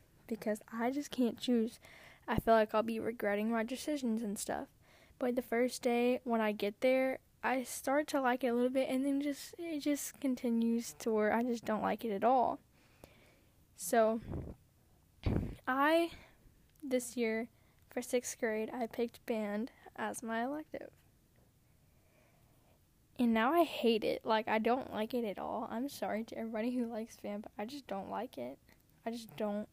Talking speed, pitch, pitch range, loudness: 175 wpm, 235 Hz, 225-260 Hz, -36 LUFS